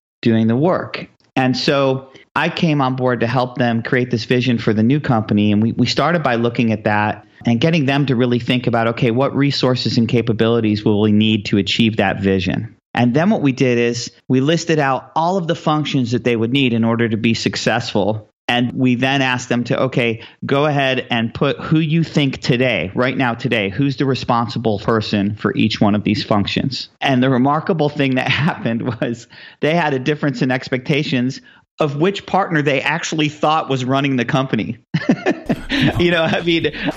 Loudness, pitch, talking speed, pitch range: -17 LUFS, 125 Hz, 200 wpm, 115-140 Hz